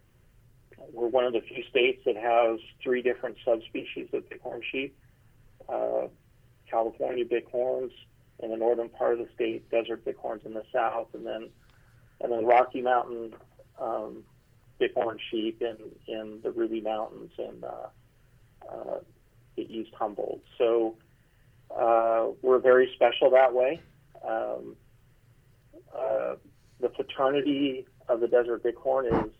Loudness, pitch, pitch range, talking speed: -28 LUFS, 120 Hz, 115-130 Hz, 130 wpm